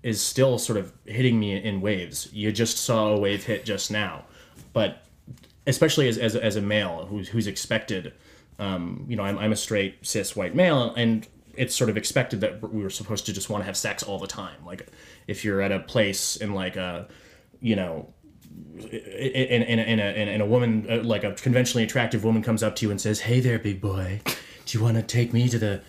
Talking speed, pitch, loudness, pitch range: 225 wpm, 110 Hz, -25 LUFS, 100-115 Hz